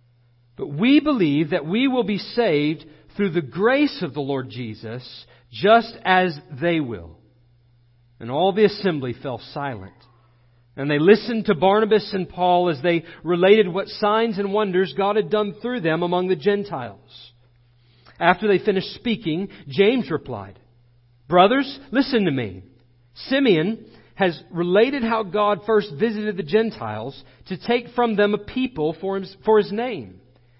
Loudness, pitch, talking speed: -21 LUFS, 180 Hz, 145 wpm